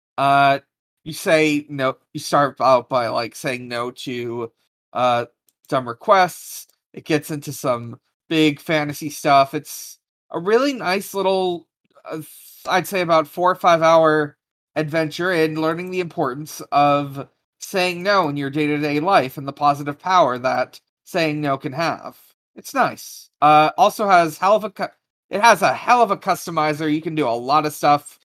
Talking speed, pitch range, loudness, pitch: 170 wpm, 140-170 Hz, -19 LUFS, 155 Hz